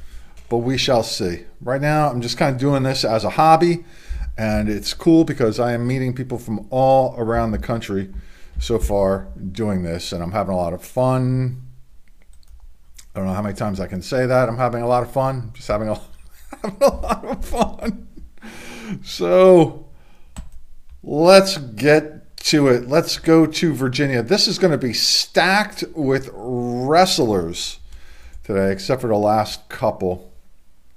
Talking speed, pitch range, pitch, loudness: 170 wpm, 90-145 Hz, 120 Hz, -19 LUFS